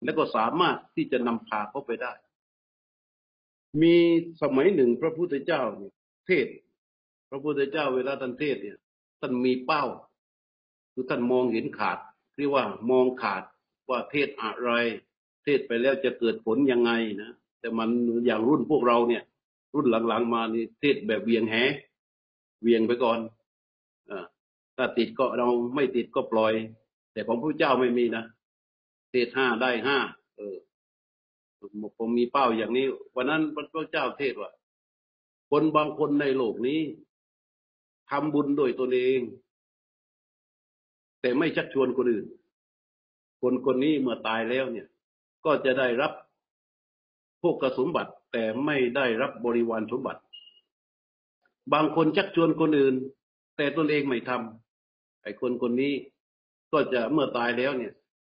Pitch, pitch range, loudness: 125 Hz, 115-140 Hz, -26 LUFS